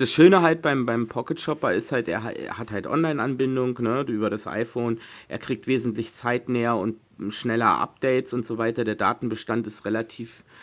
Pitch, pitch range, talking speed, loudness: 115 Hz, 115-130 Hz, 170 wpm, -24 LUFS